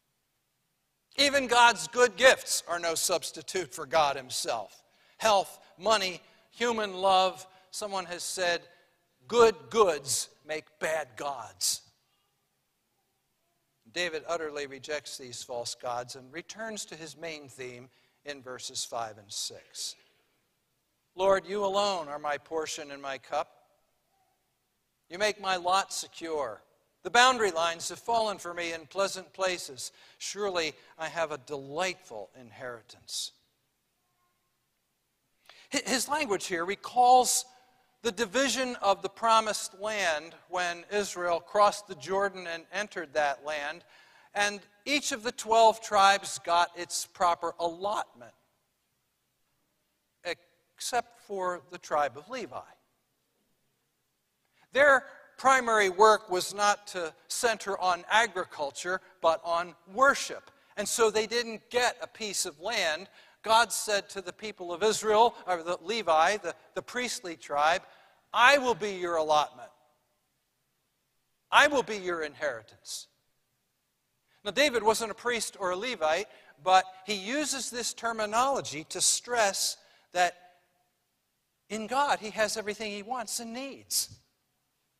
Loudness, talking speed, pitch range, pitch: -28 LUFS, 125 wpm, 165-220 Hz, 185 Hz